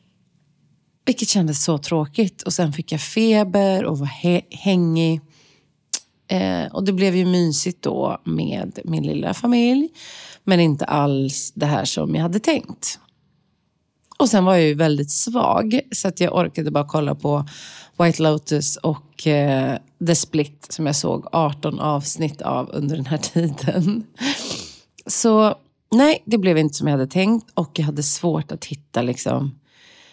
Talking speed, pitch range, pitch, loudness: 155 wpm, 150-195 Hz, 160 Hz, -20 LUFS